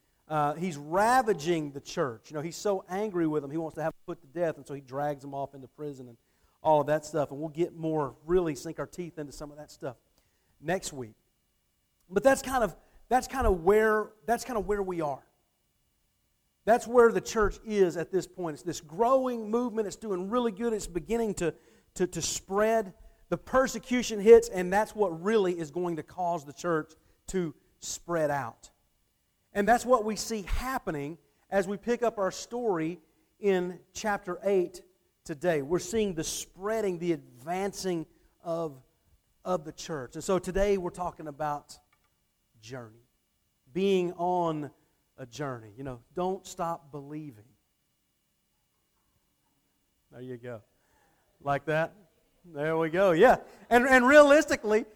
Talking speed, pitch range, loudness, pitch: 170 wpm, 150-205 Hz, -29 LUFS, 175 Hz